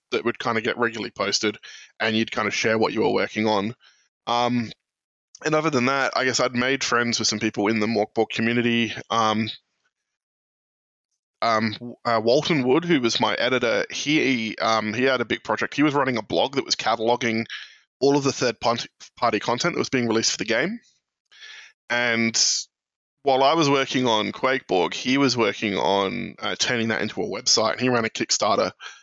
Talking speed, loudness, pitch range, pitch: 190 wpm, -22 LUFS, 110-135 Hz, 120 Hz